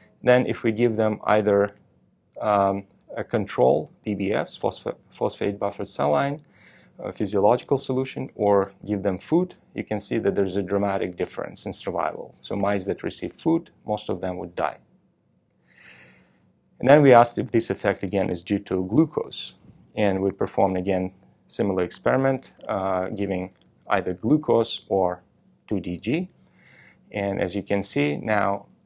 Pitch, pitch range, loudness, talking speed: 100 Hz, 95-115 Hz, -24 LUFS, 150 wpm